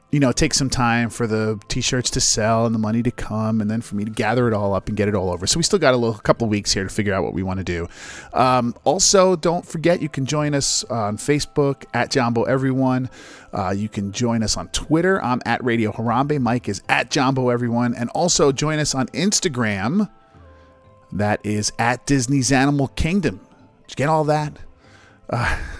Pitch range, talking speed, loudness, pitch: 105-140 Hz, 220 wpm, -20 LUFS, 120 Hz